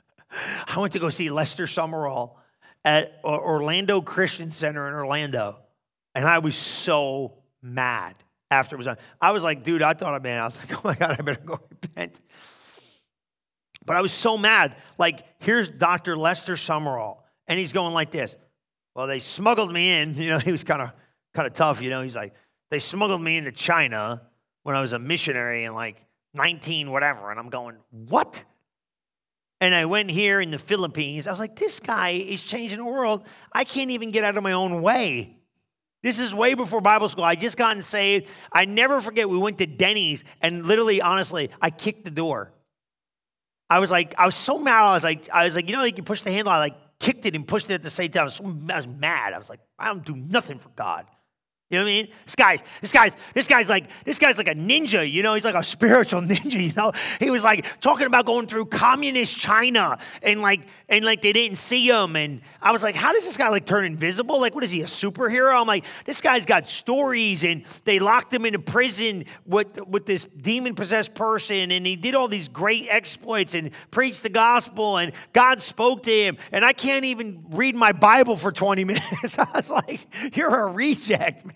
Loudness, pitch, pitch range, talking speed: -21 LUFS, 190 Hz, 160-225 Hz, 220 wpm